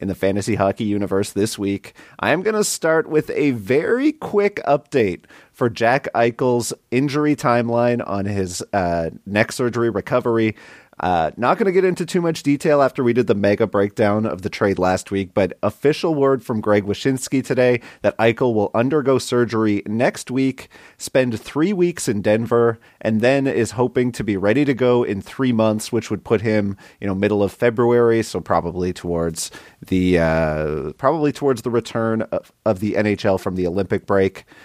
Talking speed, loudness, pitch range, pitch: 180 wpm, -19 LUFS, 100-130 Hz, 115 Hz